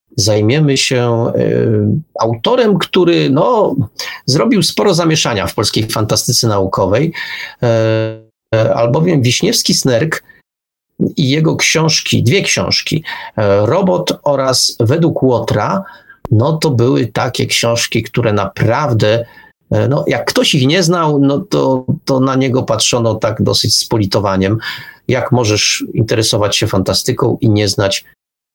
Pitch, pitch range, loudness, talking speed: 120 Hz, 110-140 Hz, -13 LUFS, 120 wpm